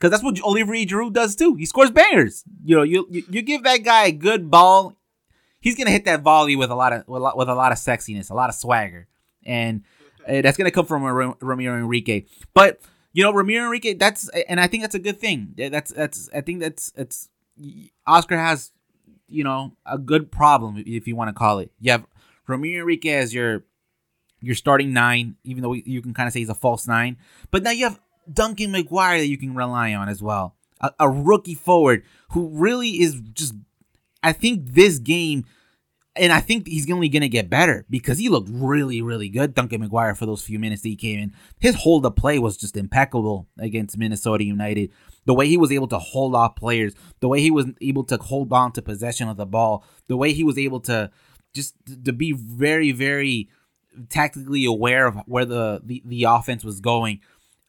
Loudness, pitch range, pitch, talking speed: -20 LUFS, 115-170 Hz, 135 Hz, 210 wpm